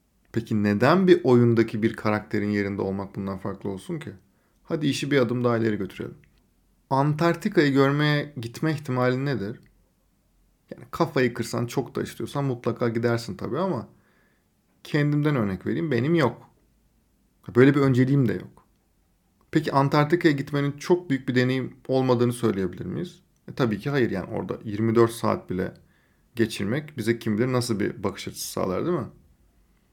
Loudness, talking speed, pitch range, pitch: -24 LUFS, 150 wpm, 110-145 Hz, 125 Hz